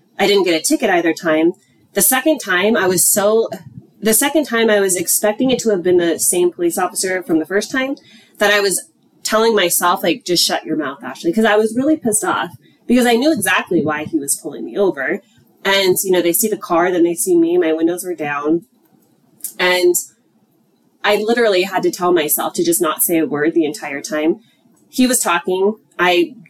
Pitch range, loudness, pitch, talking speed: 175-225 Hz, -16 LUFS, 190 Hz, 210 wpm